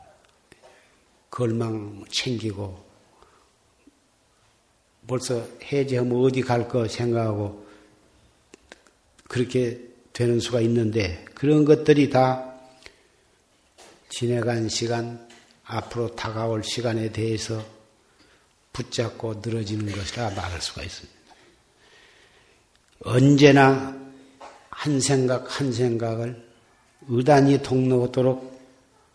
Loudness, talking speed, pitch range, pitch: -23 LUFS, 180 characters per minute, 110-130 Hz, 120 Hz